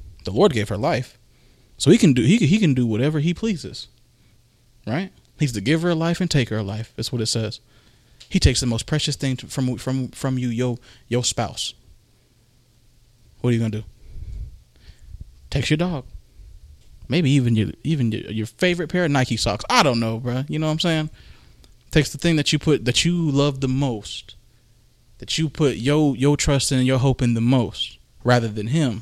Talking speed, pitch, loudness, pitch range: 210 wpm, 125 Hz, -21 LUFS, 115-145 Hz